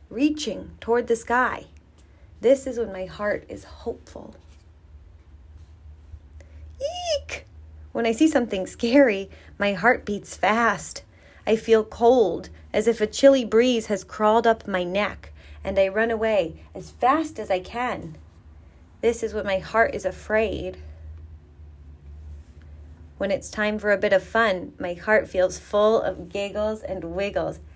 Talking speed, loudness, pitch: 145 wpm, -23 LUFS, 195 Hz